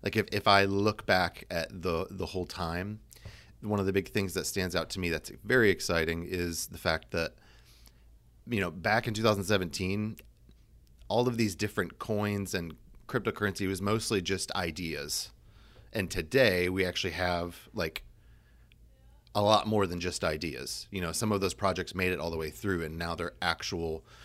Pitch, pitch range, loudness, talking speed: 95 Hz, 85-105 Hz, -31 LUFS, 180 wpm